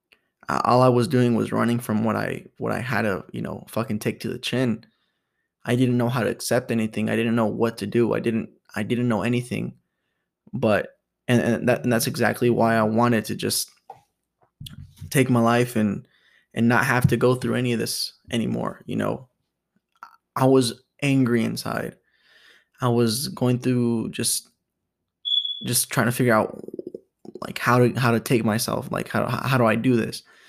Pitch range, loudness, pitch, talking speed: 115-125 Hz, -23 LUFS, 120 Hz, 185 wpm